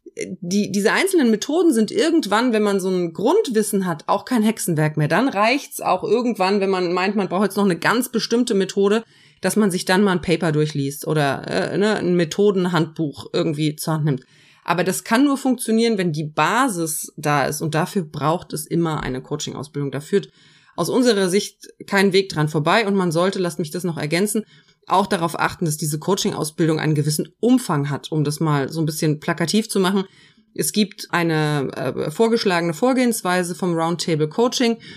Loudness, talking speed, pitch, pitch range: -20 LUFS, 190 wpm, 180 Hz, 155-210 Hz